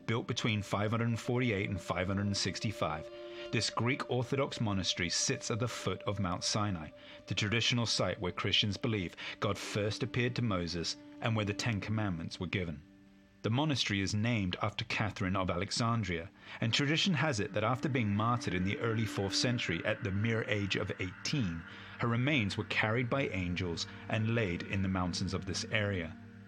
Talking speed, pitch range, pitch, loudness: 170 wpm, 95-115 Hz, 105 Hz, -34 LUFS